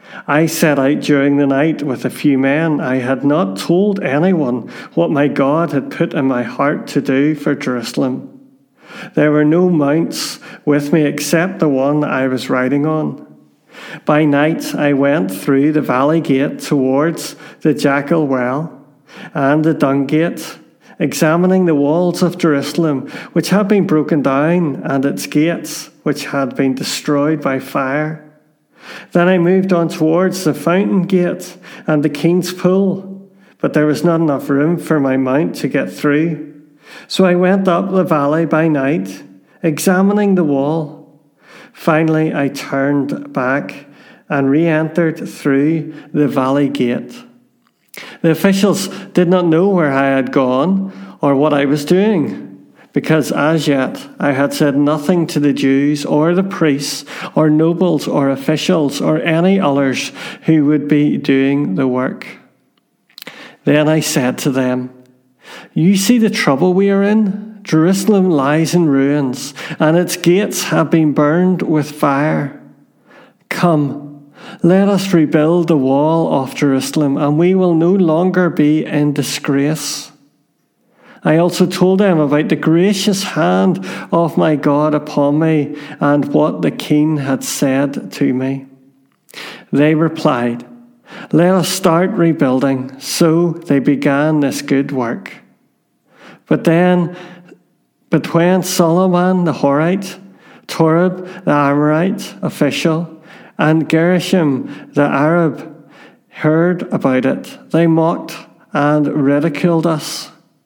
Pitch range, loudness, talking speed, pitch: 145-175 Hz, -14 LUFS, 140 wpm, 155 Hz